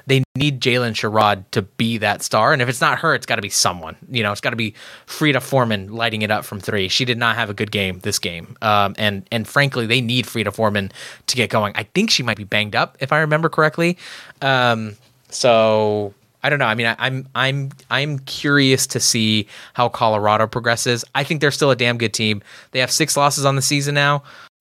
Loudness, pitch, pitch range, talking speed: -18 LUFS, 120 Hz, 105-135 Hz, 230 wpm